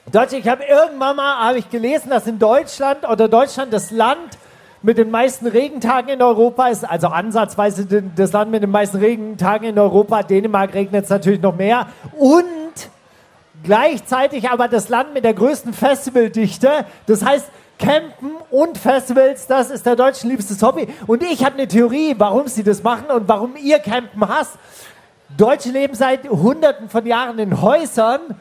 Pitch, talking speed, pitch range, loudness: 240 Hz, 170 wpm, 215-270 Hz, -16 LUFS